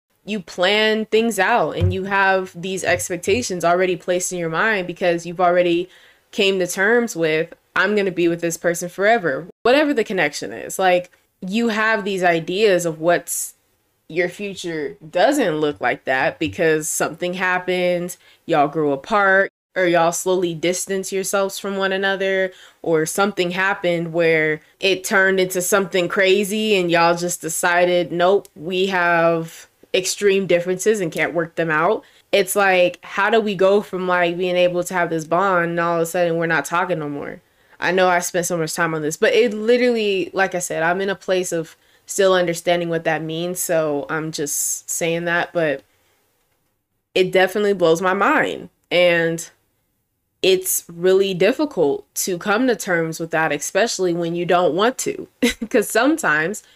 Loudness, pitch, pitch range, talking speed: -19 LUFS, 180 Hz, 170-195 Hz, 170 wpm